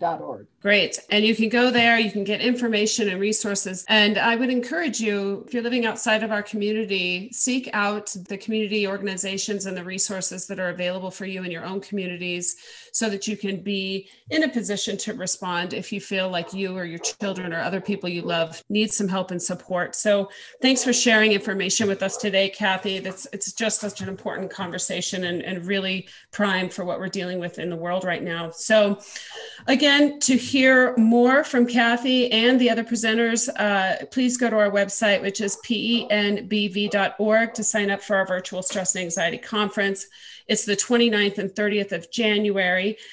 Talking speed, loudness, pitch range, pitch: 190 wpm, -22 LUFS, 190-220 Hz, 205 Hz